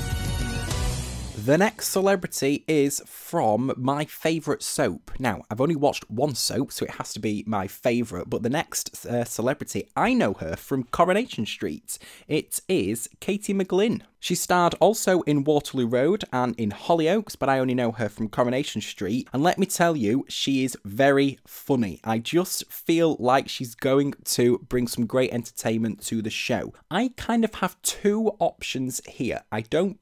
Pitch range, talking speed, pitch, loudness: 120-175 Hz, 170 wpm, 135 Hz, -25 LUFS